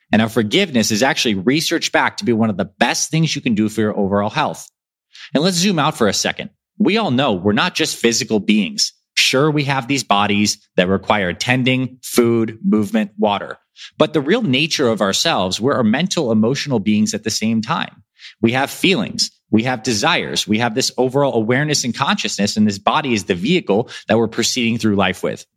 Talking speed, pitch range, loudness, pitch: 205 wpm, 105-150 Hz, -17 LUFS, 115 Hz